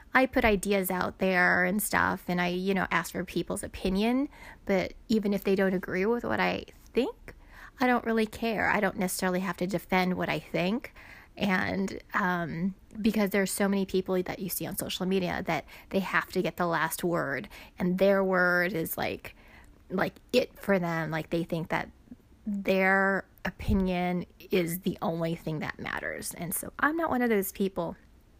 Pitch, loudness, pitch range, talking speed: 190 Hz, -29 LUFS, 175-200 Hz, 185 wpm